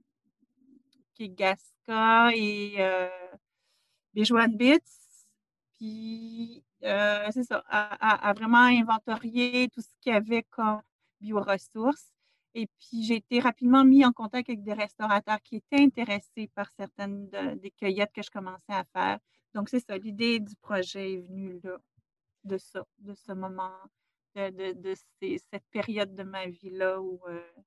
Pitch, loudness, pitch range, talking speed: 210 Hz, -27 LUFS, 195-235 Hz, 155 wpm